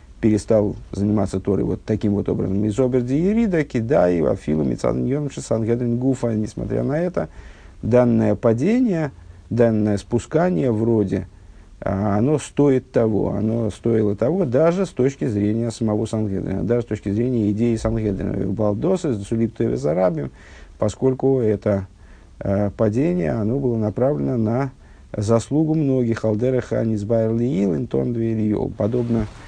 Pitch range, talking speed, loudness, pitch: 105-125 Hz, 120 wpm, -21 LUFS, 110 Hz